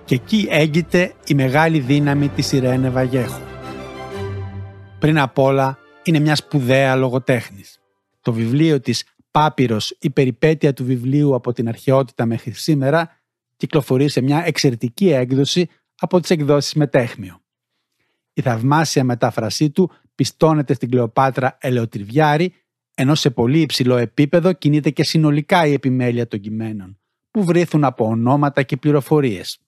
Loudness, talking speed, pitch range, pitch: -17 LUFS, 130 wpm, 120-155 Hz, 135 Hz